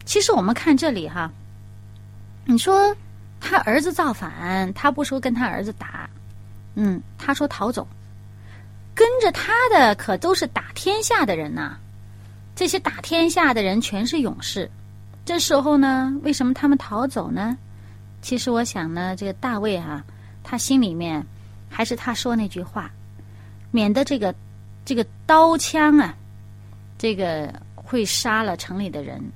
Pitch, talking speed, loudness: 200 Hz, 215 characters per minute, -21 LUFS